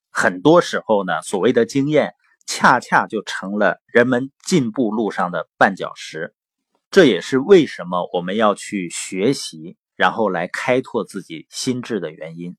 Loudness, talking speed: -18 LUFS, 235 characters per minute